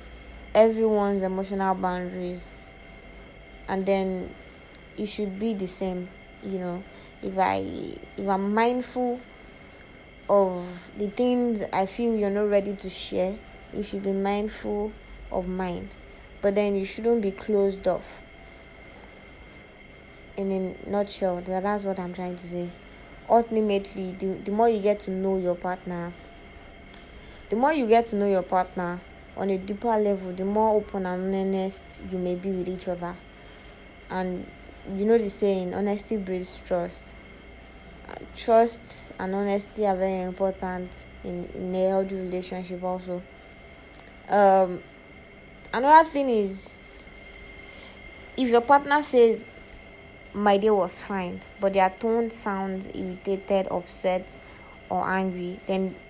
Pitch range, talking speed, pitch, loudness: 180-205 Hz, 135 wpm, 190 Hz, -26 LUFS